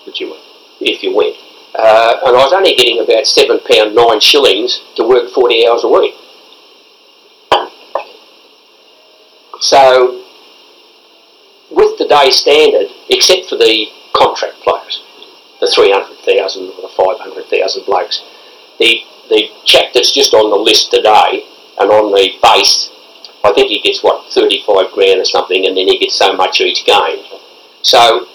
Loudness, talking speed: -9 LUFS, 150 wpm